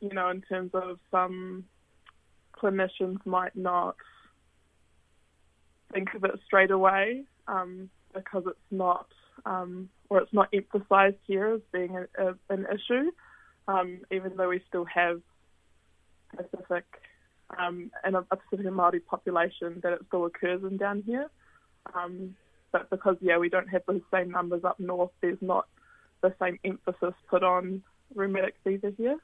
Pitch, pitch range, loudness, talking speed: 185 Hz, 180-195 Hz, -29 LUFS, 150 wpm